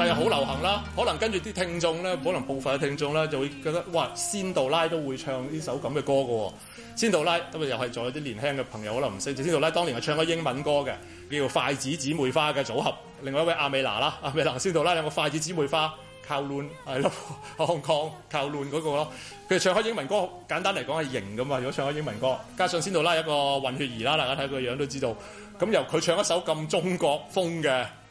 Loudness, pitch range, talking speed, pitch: -27 LUFS, 135-165 Hz, 350 characters per minute, 145 Hz